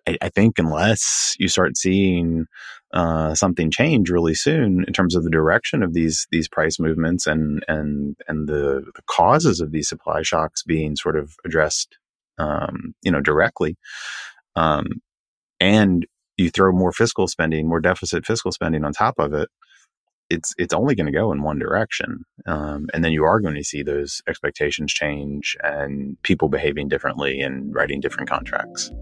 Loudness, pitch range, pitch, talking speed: -20 LUFS, 75-90 Hz, 80 Hz, 170 wpm